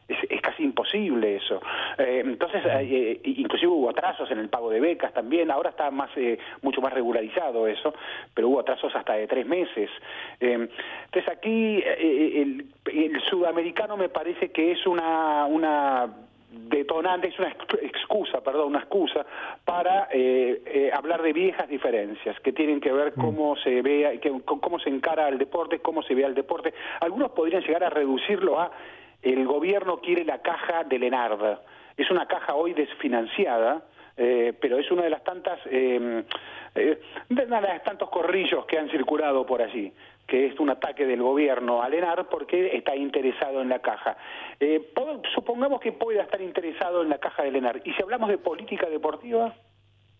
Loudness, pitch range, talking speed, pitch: -26 LUFS, 135-195 Hz, 170 wpm, 165 Hz